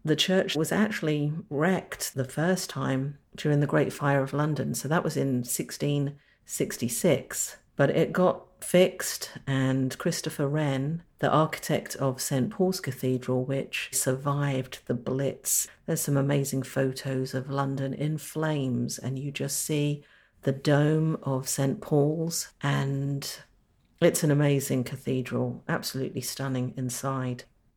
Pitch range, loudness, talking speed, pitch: 130-155 Hz, -28 LUFS, 130 wpm, 140 Hz